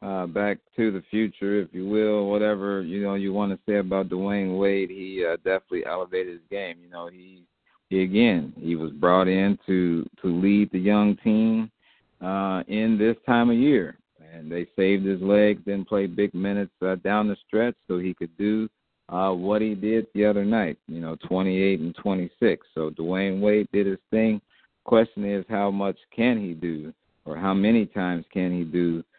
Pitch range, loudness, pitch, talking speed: 90-105 Hz, -24 LUFS, 95 Hz, 195 wpm